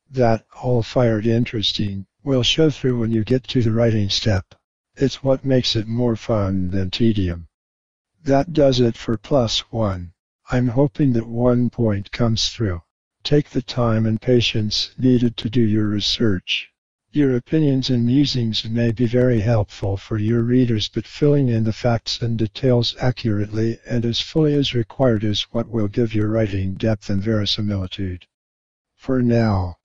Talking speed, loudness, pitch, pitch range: 160 wpm, -20 LUFS, 115 Hz, 105-125 Hz